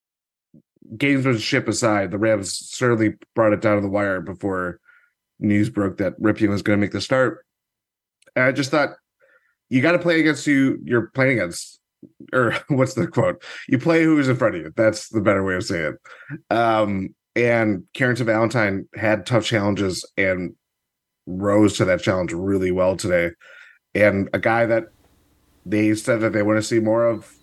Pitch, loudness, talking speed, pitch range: 110 Hz, -20 LUFS, 185 wpm, 100-120 Hz